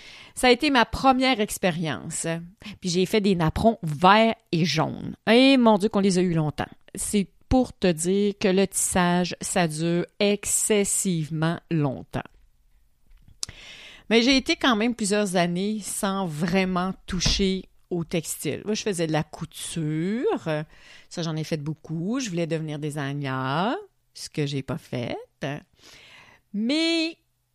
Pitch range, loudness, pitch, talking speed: 160-215 Hz, -24 LUFS, 185 Hz, 145 wpm